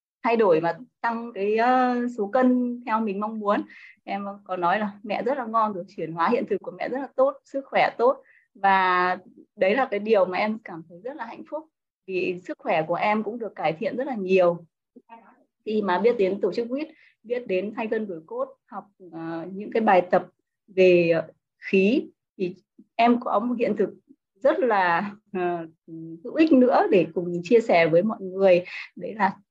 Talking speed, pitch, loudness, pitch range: 195 wpm, 210 Hz, -24 LUFS, 185-245 Hz